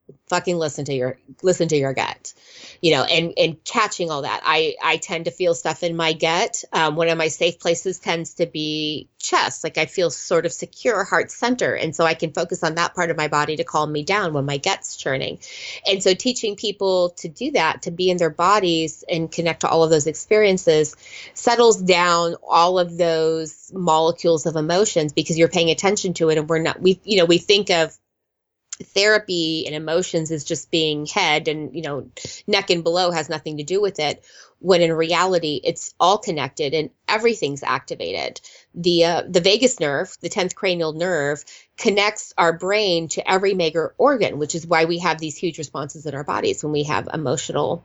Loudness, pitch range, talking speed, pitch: -20 LUFS, 160-185 Hz, 205 wpm, 170 Hz